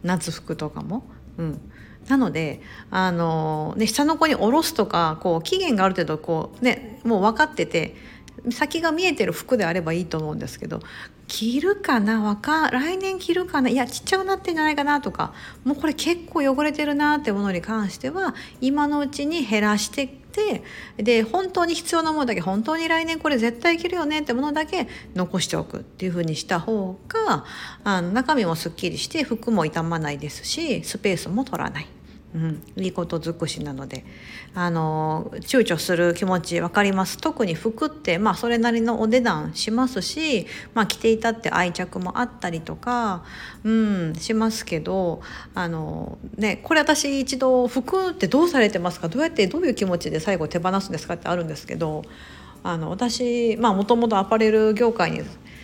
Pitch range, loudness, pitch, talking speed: 175-285 Hz, -23 LUFS, 225 Hz, 360 characters per minute